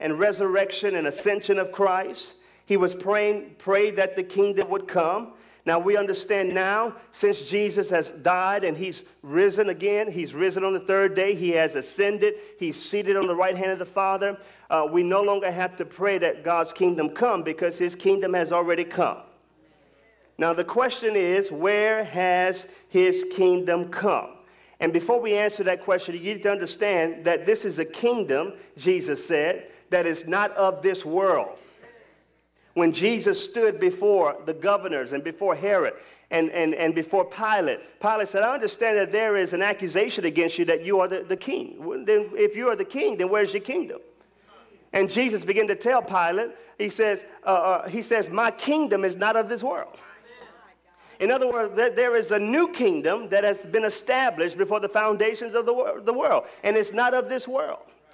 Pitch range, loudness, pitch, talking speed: 185-230 Hz, -24 LUFS, 200 Hz, 185 wpm